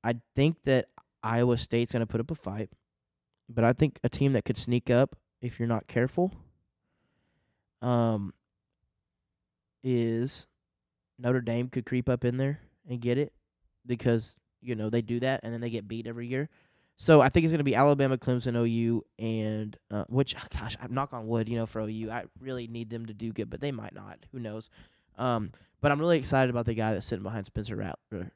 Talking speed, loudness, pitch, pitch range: 205 wpm, -29 LUFS, 120 Hz, 110-130 Hz